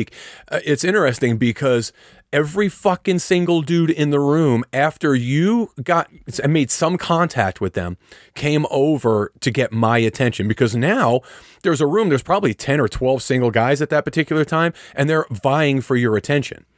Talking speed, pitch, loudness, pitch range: 170 wpm, 145 Hz, -18 LUFS, 125-160 Hz